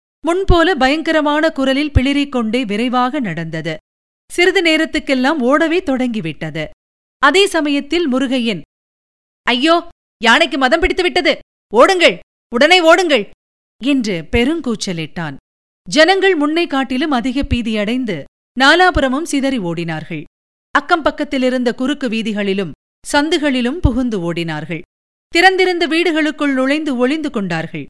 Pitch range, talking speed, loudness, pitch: 225-315 Hz, 95 wpm, -15 LUFS, 270 Hz